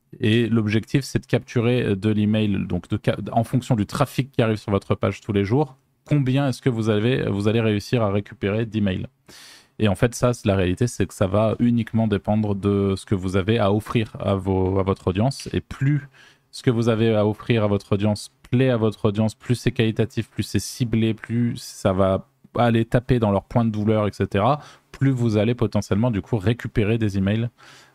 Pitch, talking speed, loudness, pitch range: 110 Hz, 215 wpm, -22 LUFS, 105-125 Hz